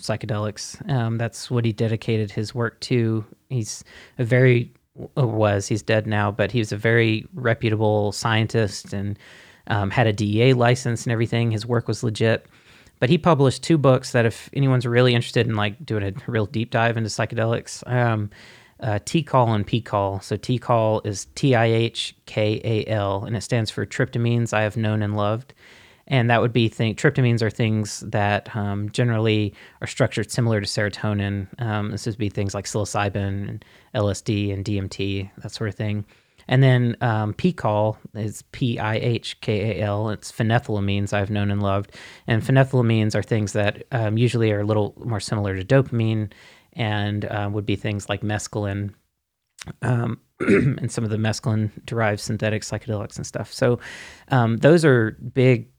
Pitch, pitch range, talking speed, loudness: 110 Hz, 105-120 Hz, 170 wpm, -22 LUFS